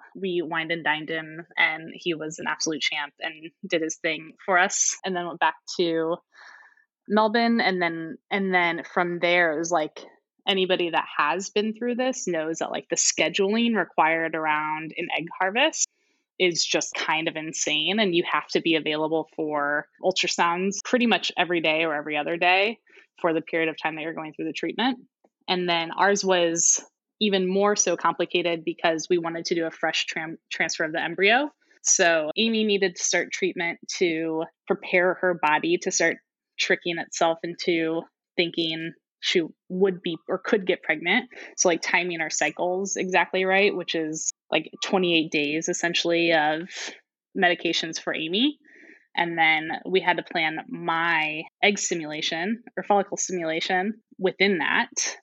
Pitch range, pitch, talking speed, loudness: 165-195 Hz, 175 Hz, 165 wpm, -24 LUFS